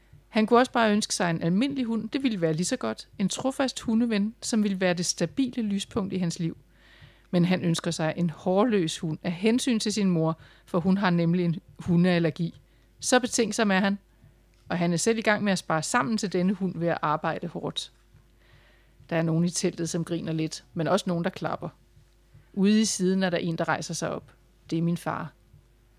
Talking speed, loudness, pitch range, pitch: 215 wpm, -26 LUFS, 165-210 Hz, 180 Hz